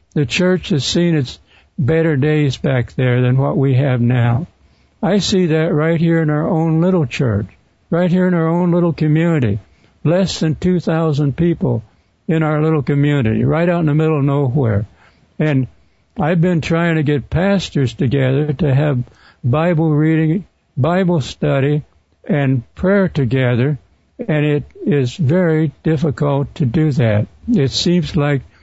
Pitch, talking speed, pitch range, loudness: 150 Hz, 155 wpm, 130-165 Hz, -16 LUFS